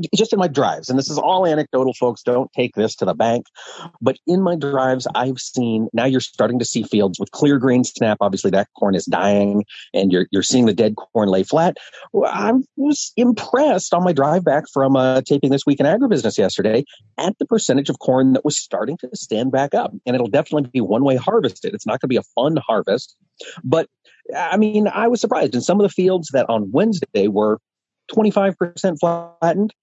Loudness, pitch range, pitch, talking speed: -18 LUFS, 115-180 Hz, 135 Hz, 215 wpm